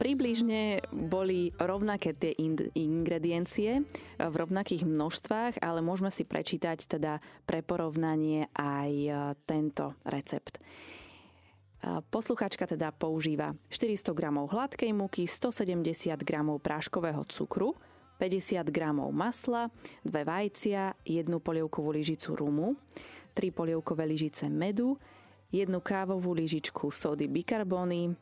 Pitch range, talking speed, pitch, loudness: 155-200 Hz, 100 wpm, 170 Hz, -33 LUFS